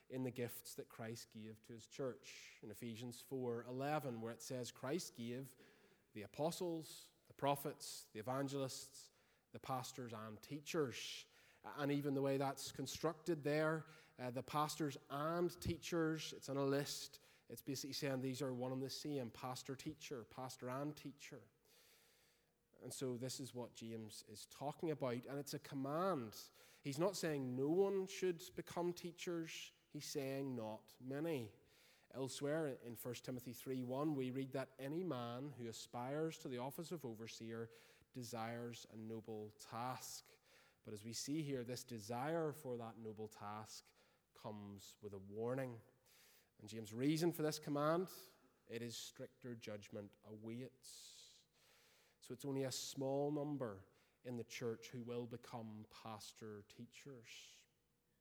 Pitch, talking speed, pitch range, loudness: 130 Hz, 145 wpm, 115-150 Hz, -46 LUFS